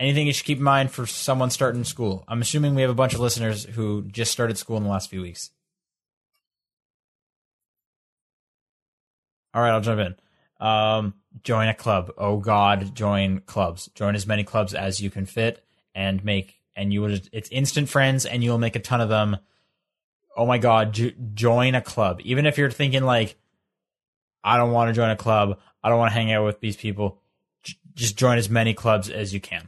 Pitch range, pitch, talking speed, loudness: 100-125 Hz, 110 Hz, 205 wpm, -23 LUFS